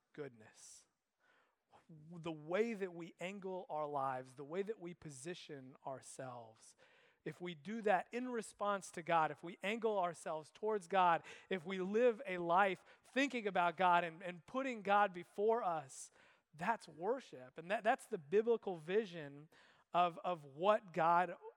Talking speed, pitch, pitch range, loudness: 150 wpm, 180 Hz, 160-210 Hz, -39 LUFS